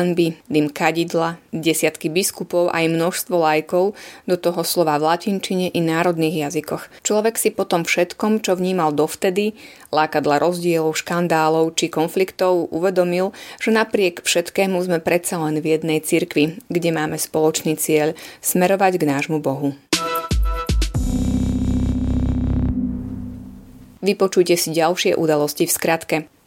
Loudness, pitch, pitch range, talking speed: -19 LUFS, 165 Hz, 155-180 Hz, 120 wpm